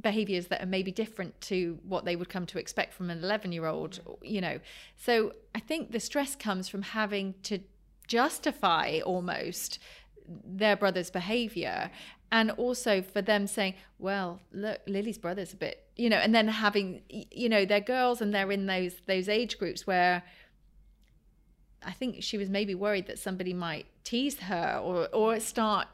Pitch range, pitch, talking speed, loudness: 185-220 Hz, 200 Hz, 175 wpm, -31 LUFS